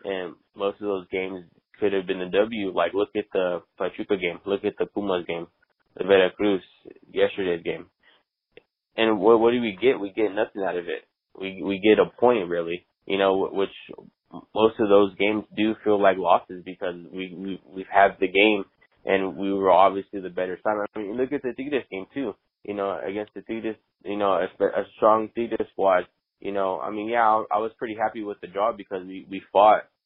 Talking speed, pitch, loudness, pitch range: 215 wpm, 100 Hz, -24 LUFS, 95-110 Hz